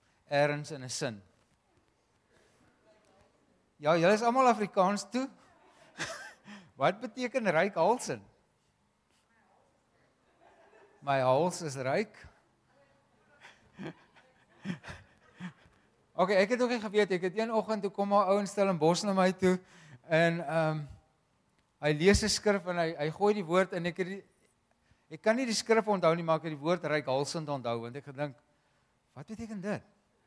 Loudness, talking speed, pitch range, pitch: -30 LUFS, 150 wpm, 150-205 Hz, 180 Hz